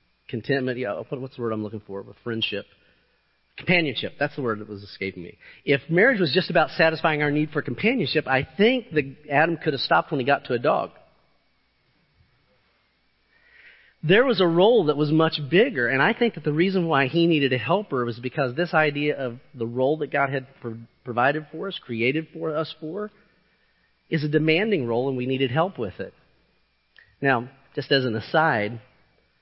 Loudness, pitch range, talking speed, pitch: -23 LUFS, 125-160 Hz, 185 wpm, 145 Hz